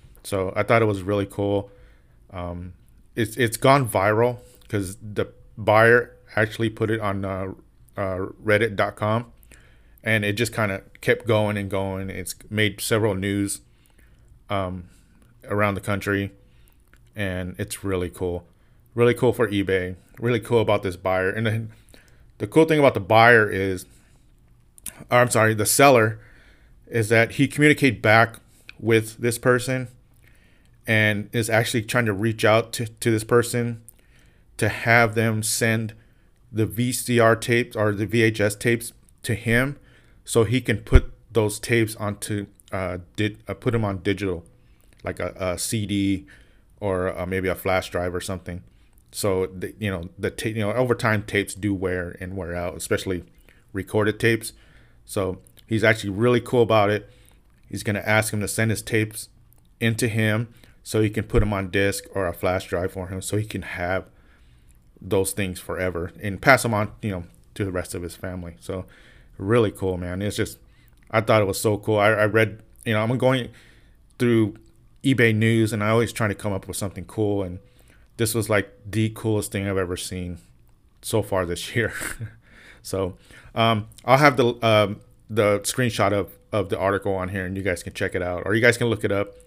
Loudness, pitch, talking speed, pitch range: -23 LUFS, 105 Hz, 180 wpm, 95-115 Hz